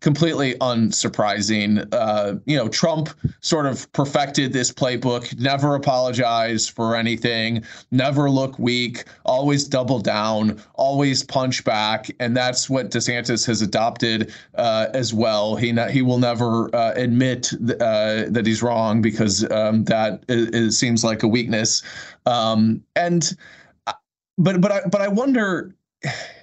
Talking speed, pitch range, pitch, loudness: 140 wpm, 110-135 Hz, 120 Hz, -20 LUFS